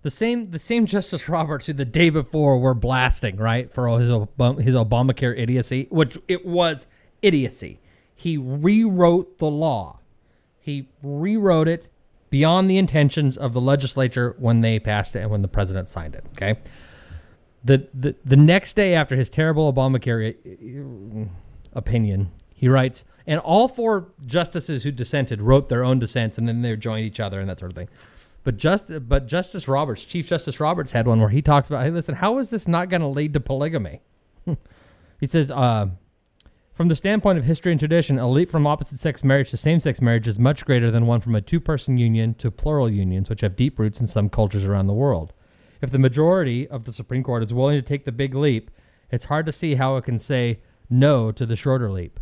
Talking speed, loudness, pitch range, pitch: 200 wpm, -21 LUFS, 115-155 Hz, 130 Hz